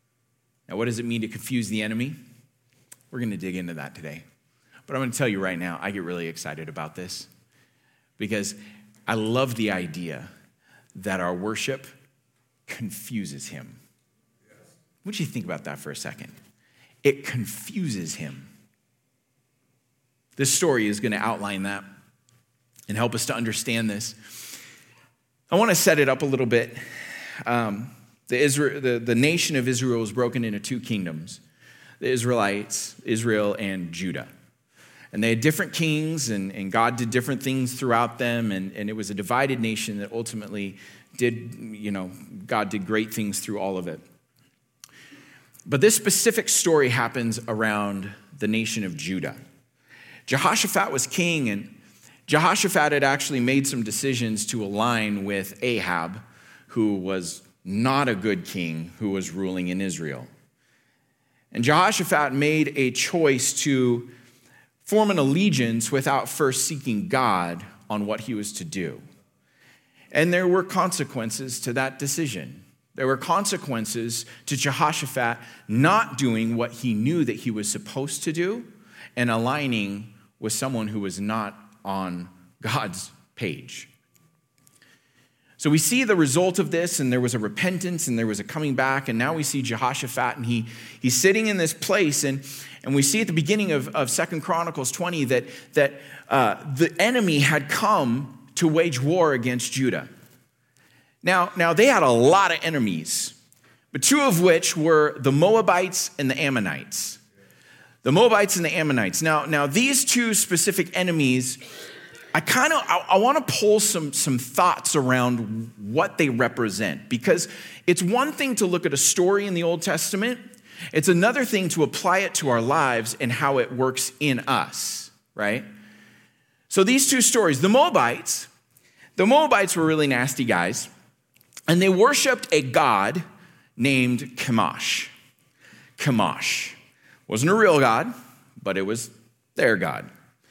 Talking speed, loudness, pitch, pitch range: 155 wpm, -23 LUFS, 130 Hz, 110-155 Hz